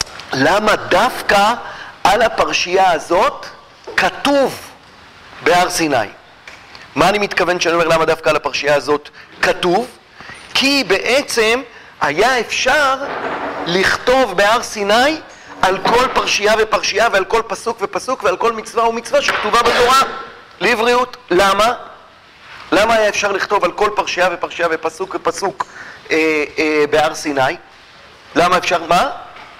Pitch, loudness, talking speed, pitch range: 205 Hz, -15 LUFS, 120 wpm, 170-240 Hz